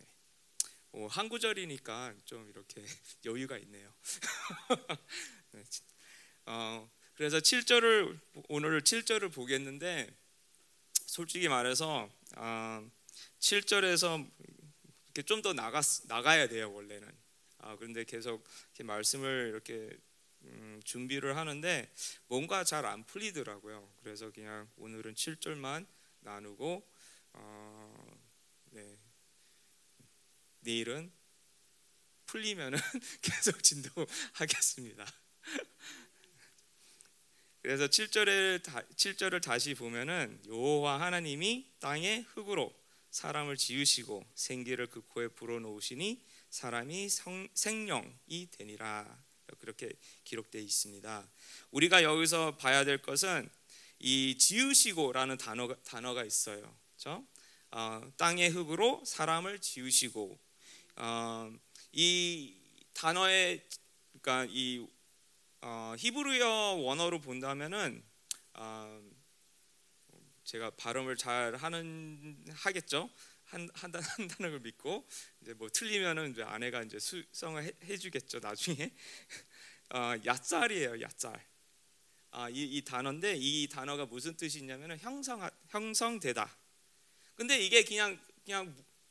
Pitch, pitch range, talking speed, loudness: 140 Hz, 115-180 Hz, 225 characters per minute, -33 LUFS